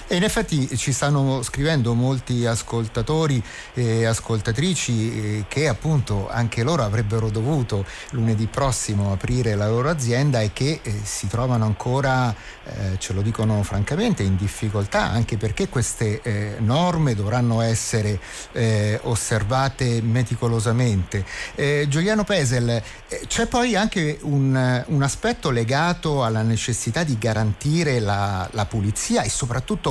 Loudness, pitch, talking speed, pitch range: -22 LUFS, 120 Hz, 125 wpm, 110-140 Hz